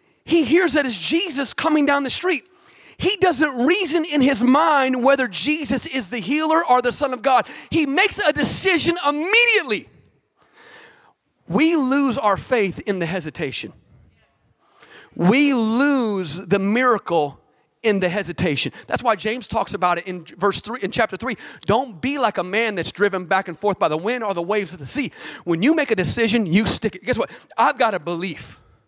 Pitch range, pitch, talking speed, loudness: 195-300 Hz, 250 Hz, 185 wpm, -19 LUFS